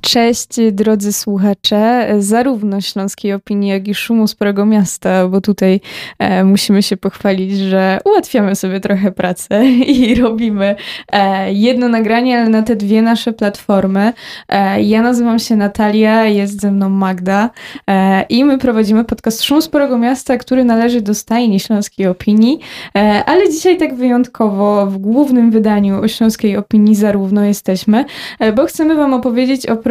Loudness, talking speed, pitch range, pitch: -13 LUFS, 140 wpm, 200-240 Hz, 215 Hz